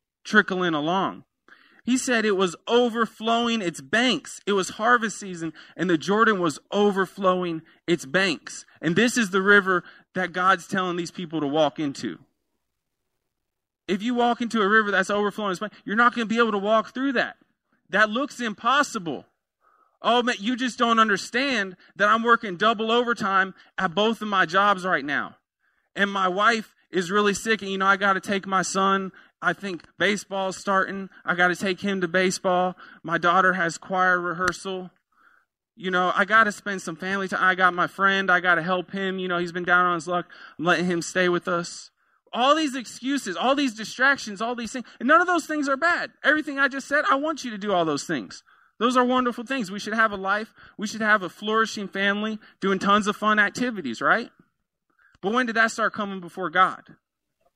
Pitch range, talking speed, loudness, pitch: 185-230 Hz, 200 wpm, -23 LUFS, 200 Hz